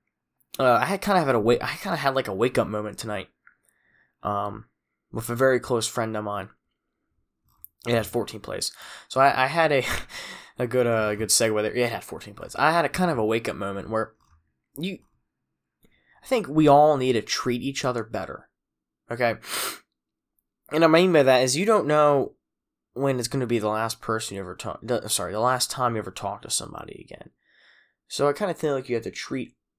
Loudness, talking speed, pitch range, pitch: -24 LUFS, 220 wpm, 105-140 Hz, 120 Hz